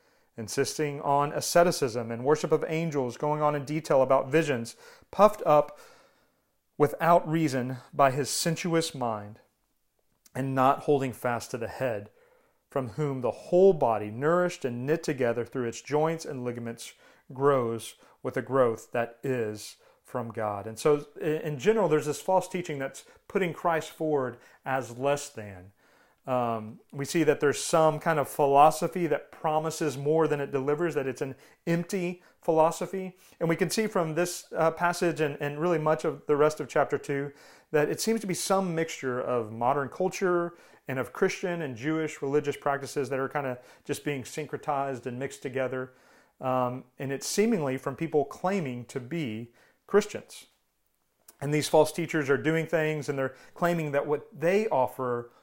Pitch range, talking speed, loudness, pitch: 130-165 Hz, 165 wpm, -28 LUFS, 150 Hz